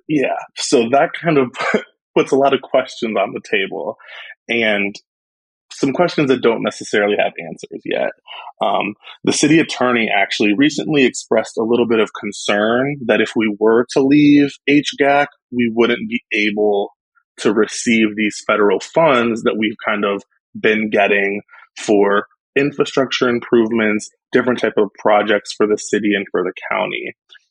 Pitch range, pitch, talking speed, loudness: 105-130 Hz, 115 Hz, 155 wpm, -16 LUFS